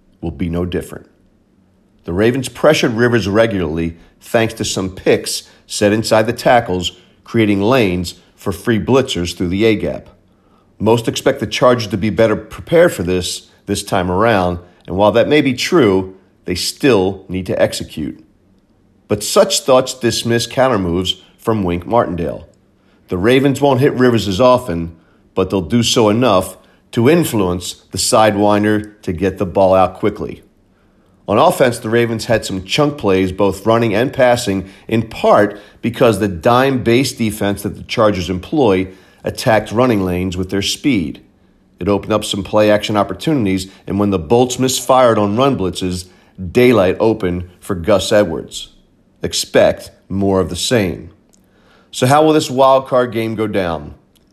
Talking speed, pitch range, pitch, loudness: 155 wpm, 95-120 Hz, 105 Hz, -15 LUFS